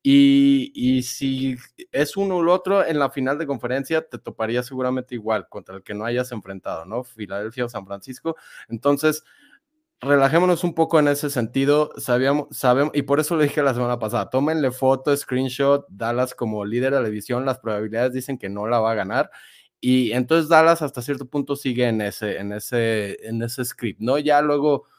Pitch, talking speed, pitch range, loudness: 130 Hz, 190 wpm, 120-145 Hz, -22 LUFS